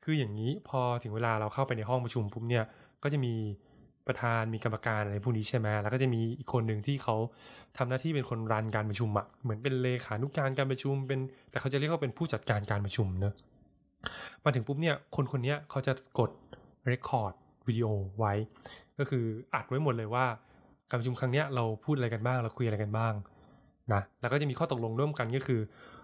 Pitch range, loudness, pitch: 110-135 Hz, -33 LUFS, 125 Hz